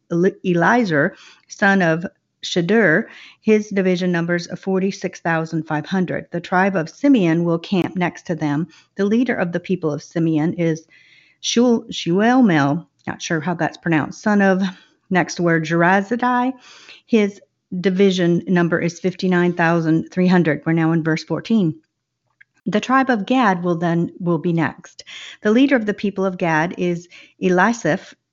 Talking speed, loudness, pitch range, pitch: 140 wpm, -19 LUFS, 165-200 Hz, 180 Hz